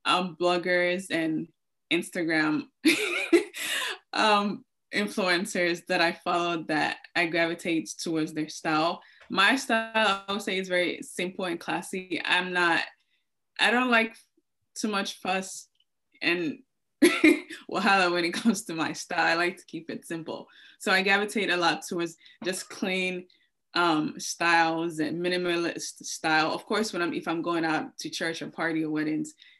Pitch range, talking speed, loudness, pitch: 170-220 Hz, 150 wpm, -27 LUFS, 180 Hz